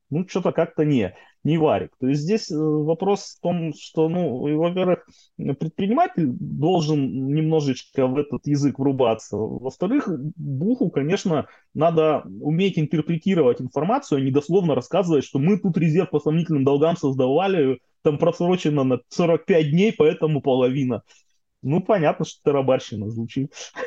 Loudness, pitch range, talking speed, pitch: -22 LUFS, 140-175 Hz, 135 wpm, 155 Hz